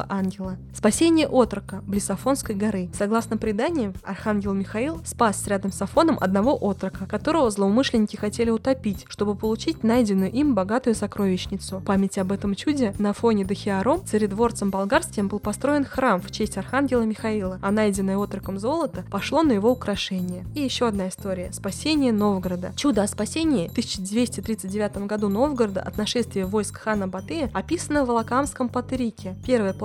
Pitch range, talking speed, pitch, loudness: 195-250 Hz, 145 wpm, 215 Hz, -24 LUFS